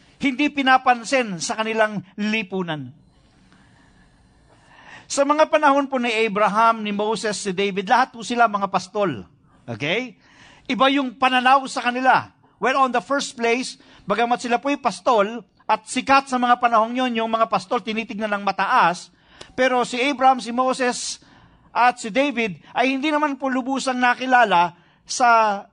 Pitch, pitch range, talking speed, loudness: 240 Hz, 215-260 Hz, 145 wpm, -20 LUFS